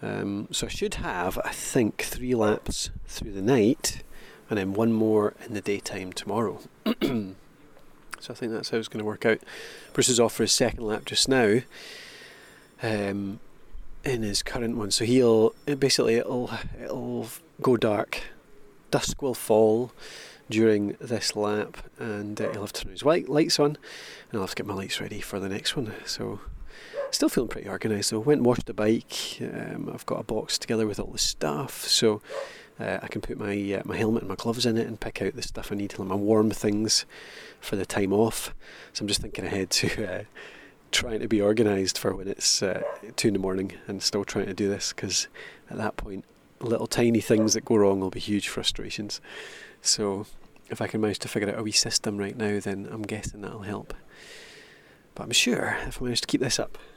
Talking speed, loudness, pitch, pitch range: 210 wpm, -26 LUFS, 110 Hz, 100-115 Hz